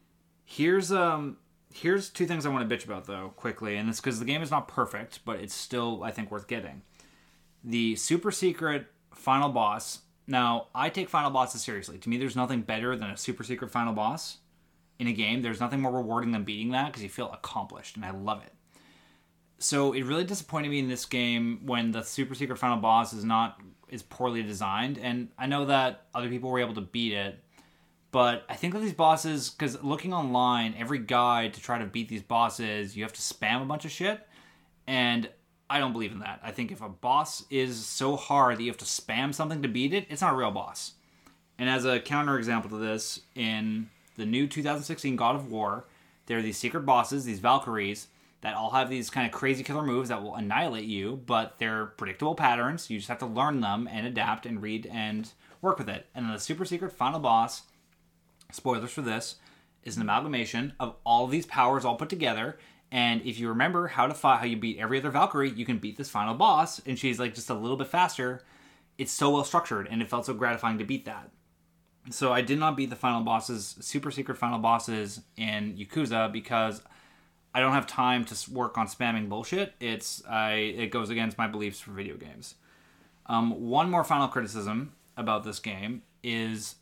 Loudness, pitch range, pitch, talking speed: -29 LUFS, 110-135 Hz, 120 Hz, 210 wpm